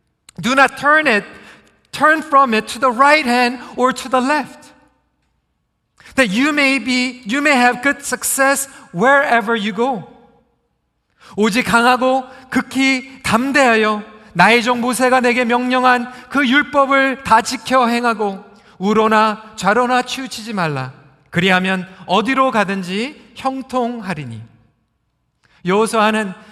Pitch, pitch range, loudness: 245 Hz, 215-265 Hz, -15 LUFS